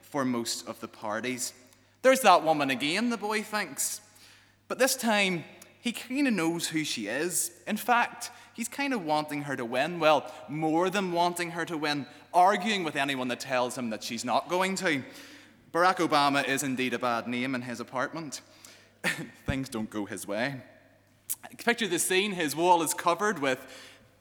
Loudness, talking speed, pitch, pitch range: -28 LUFS, 180 wpm, 155 Hz, 125-190 Hz